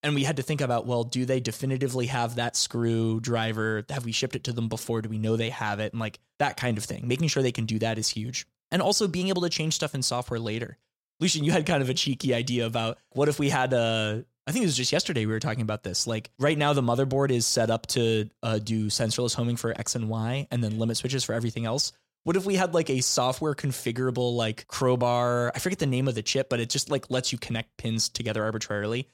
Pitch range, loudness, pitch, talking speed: 115-135 Hz, -27 LUFS, 120 Hz, 260 wpm